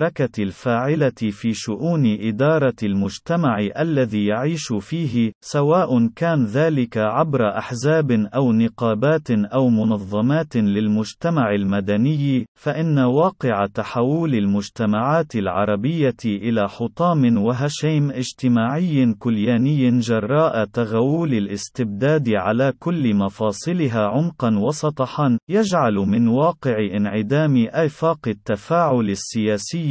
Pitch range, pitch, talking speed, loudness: 110-150 Hz, 120 Hz, 90 wpm, -20 LUFS